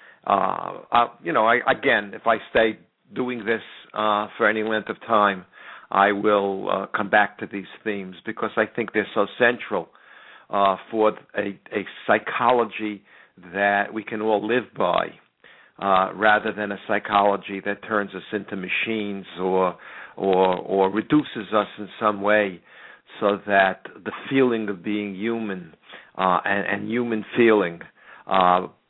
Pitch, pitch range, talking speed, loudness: 105 Hz, 100-110 Hz, 150 wpm, -23 LUFS